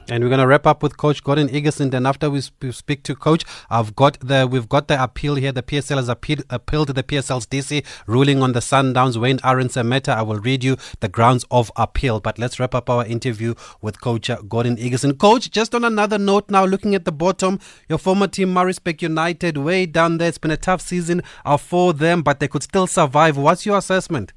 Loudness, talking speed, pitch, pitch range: -18 LUFS, 225 wpm, 140 Hz, 125-170 Hz